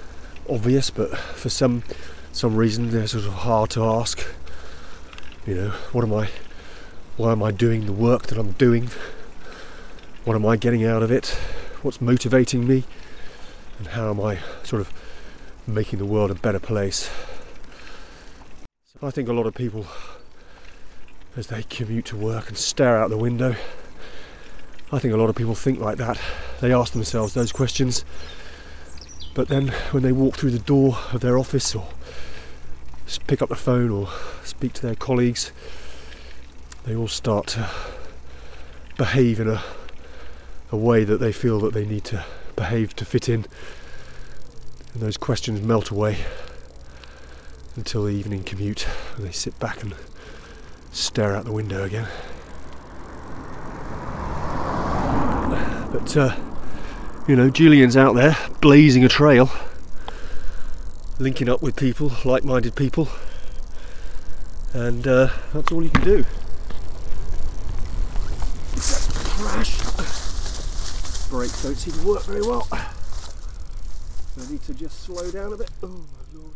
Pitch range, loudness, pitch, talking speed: 75-120 Hz, -22 LUFS, 110 Hz, 140 wpm